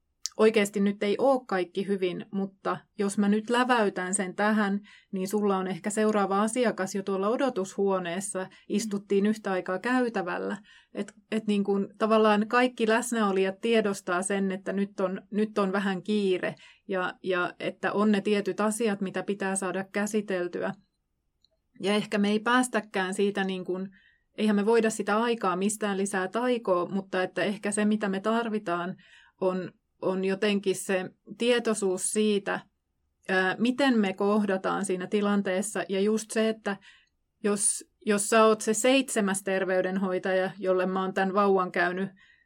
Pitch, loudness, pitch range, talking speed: 200 Hz, -27 LUFS, 190-215 Hz, 145 wpm